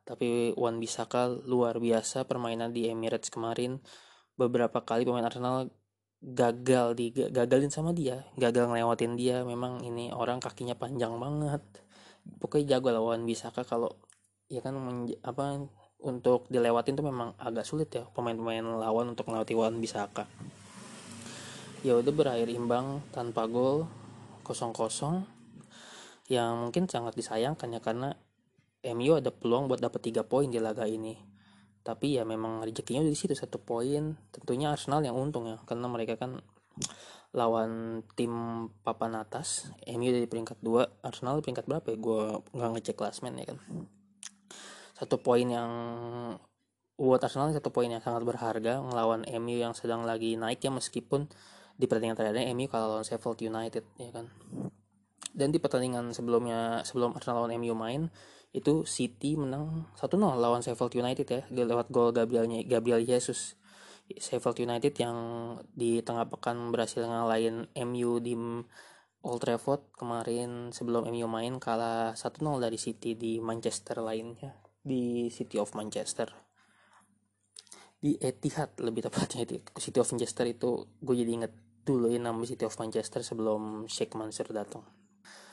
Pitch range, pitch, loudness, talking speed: 115-130 Hz, 120 Hz, -32 LUFS, 145 wpm